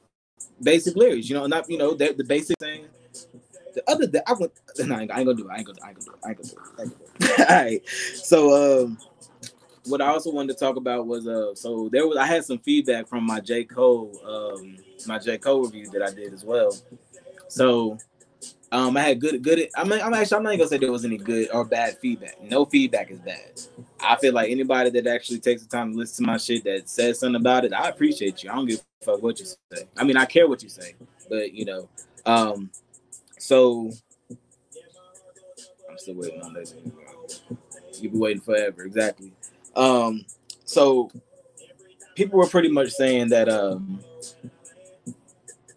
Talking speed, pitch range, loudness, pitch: 205 wpm, 120-175 Hz, -22 LUFS, 130 Hz